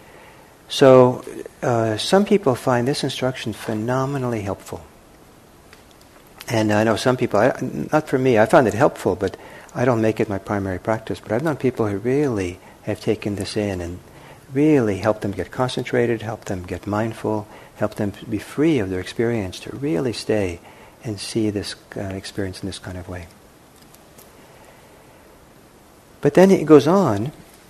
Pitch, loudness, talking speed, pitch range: 110 Hz, -20 LUFS, 165 wpm, 100-130 Hz